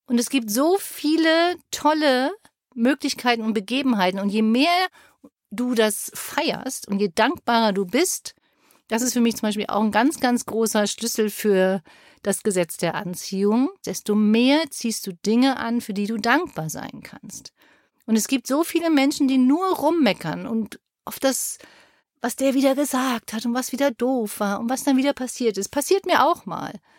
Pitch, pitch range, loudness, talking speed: 245 Hz, 220-285 Hz, -22 LUFS, 180 wpm